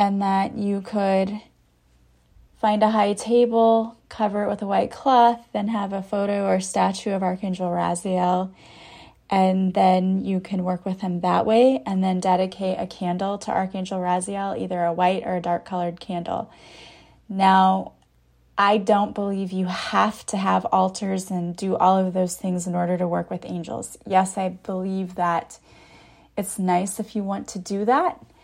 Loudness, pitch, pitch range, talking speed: -23 LUFS, 190 Hz, 180-205 Hz, 170 wpm